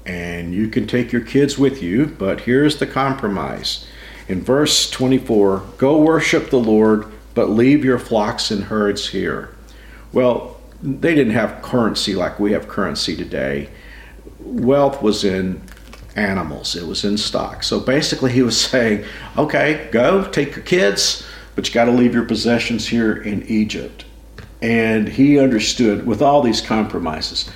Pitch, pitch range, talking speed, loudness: 115 Hz, 105-130 Hz, 155 wpm, -17 LUFS